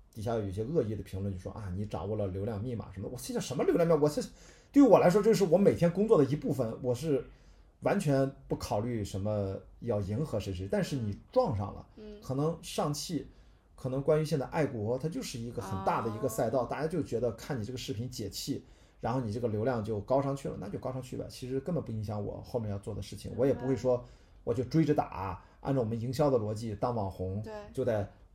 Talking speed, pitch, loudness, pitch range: 350 characters per minute, 125 Hz, -32 LUFS, 105-140 Hz